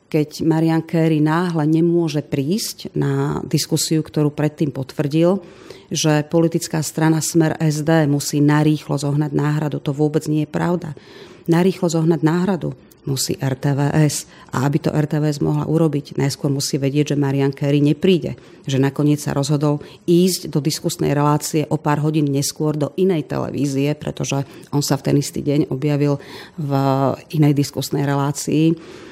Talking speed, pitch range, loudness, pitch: 145 wpm, 145-165 Hz, -19 LUFS, 150 Hz